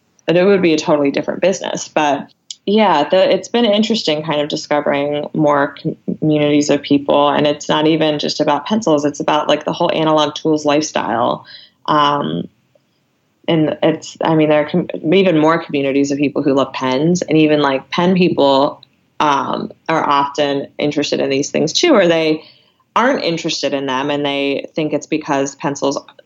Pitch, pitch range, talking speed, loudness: 150 Hz, 145-160 Hz, 175 wpm, -15 LUFS